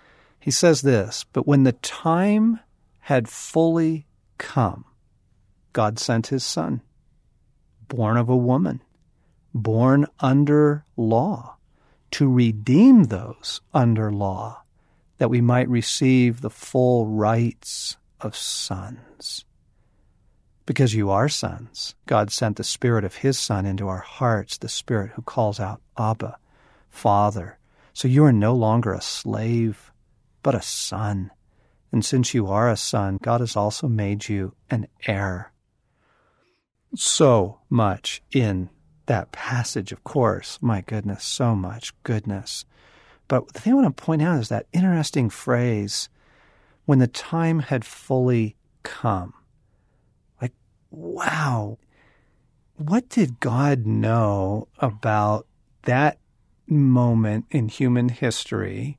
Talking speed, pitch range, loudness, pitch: 125 wpm, 105-135 Hz, -22 LUFS, 115 Hz